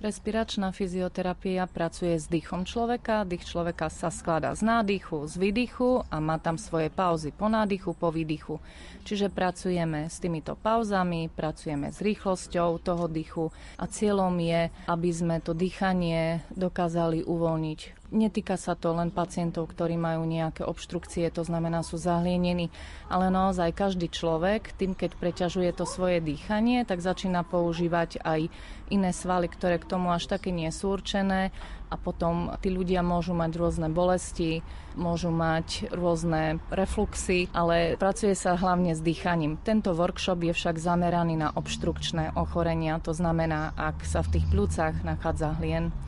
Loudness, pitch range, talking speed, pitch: -28 LUFS, 165-185 Hz, 150 wpm, 175 Hz